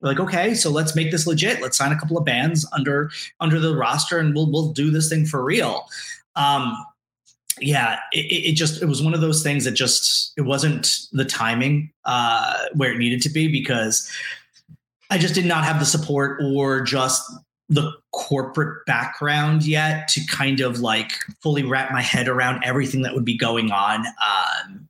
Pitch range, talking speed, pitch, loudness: 130-160 Hz, 190 wpm, 145 Hz, -20 LUFS